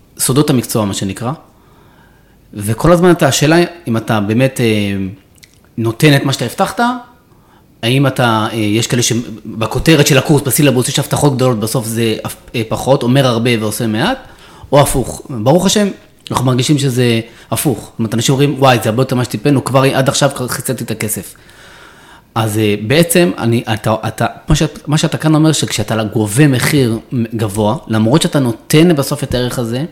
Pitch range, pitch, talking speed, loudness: 110-145 Hz, 125 Hz, 175 wpm, -13 LUFS